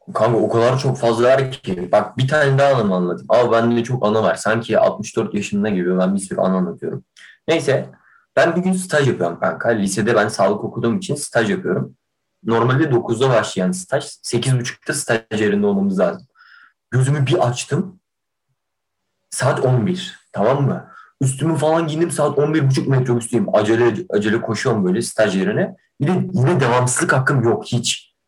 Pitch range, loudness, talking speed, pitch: 115-150 Hz, -18 LUFS, 165 wpm, 125 Hz